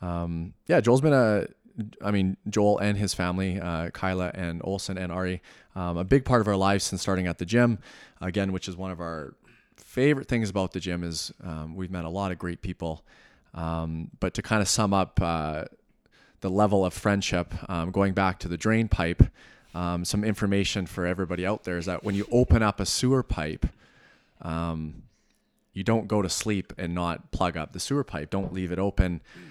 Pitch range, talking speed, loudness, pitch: 85-105 Hz, 200 wpm, -27 LUFS, 95 Hz